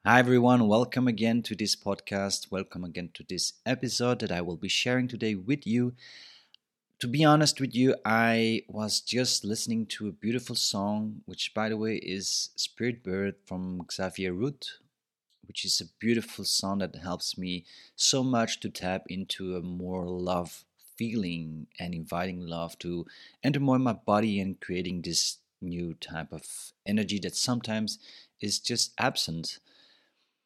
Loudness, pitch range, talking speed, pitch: -29 LUFS, 90-120 Hz, 160 wpm, 105 Hz